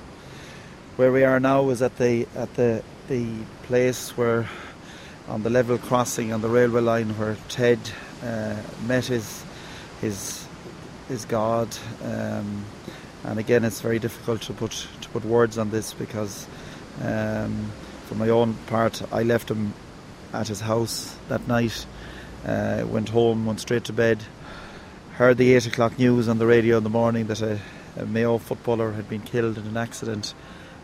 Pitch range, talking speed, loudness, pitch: 110-120 Hz, 165 wpm, -24 LUFS, 115 Hz